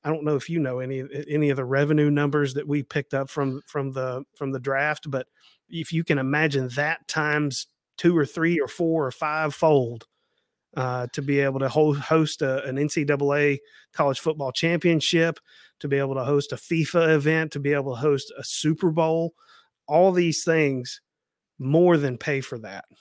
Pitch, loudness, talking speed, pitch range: 145 Hz, -24 LUFS, 190 wpm, 135-160 Hz